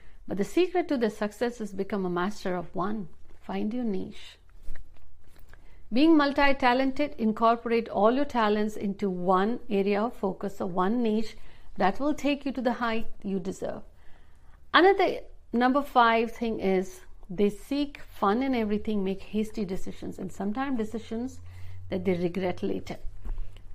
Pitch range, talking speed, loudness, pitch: 190-240 Hz, 150 wpm, -28 LUFS, 210 Hz